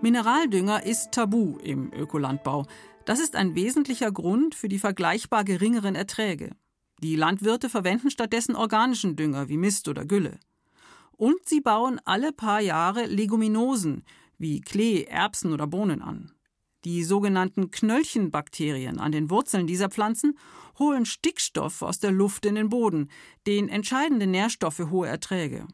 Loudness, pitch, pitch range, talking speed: -25 LUFS, 205 Hz, 175-230 Hz, 140 wpm